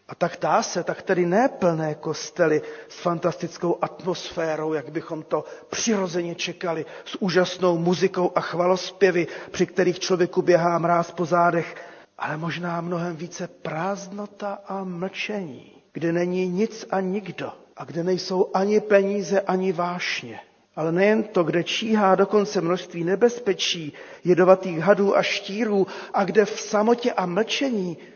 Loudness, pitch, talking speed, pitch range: -23 LUFS, 180 Hz, 140 wpm, 170-200 Hz